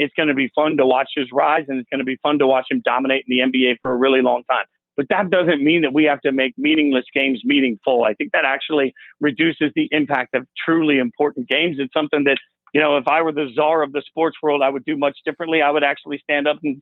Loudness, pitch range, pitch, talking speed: -18 LUFS, 130-150 Hz, 145 Hz, 270 wpm